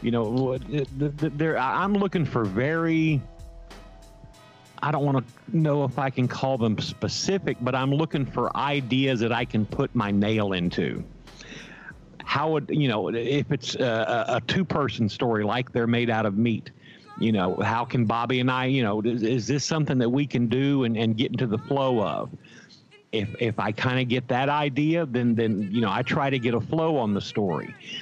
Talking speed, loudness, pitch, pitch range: 195 wpm, -25 LUFS, 125 Hz, 115-140 Hz